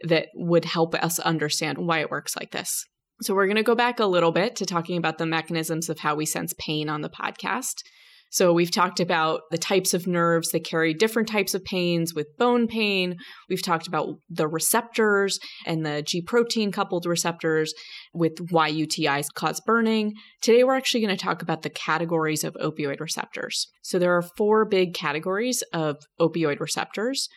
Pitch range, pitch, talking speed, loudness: 160-210 Hz, 170 Hz, 185 wpm, -24 LUFS